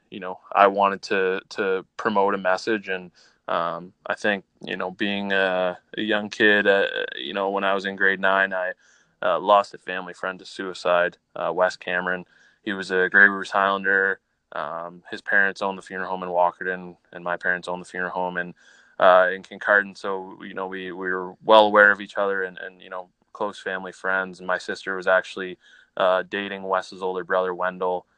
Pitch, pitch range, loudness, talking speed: 95 Hz, 90-100 Hz, -23 LUFS, 200 wpm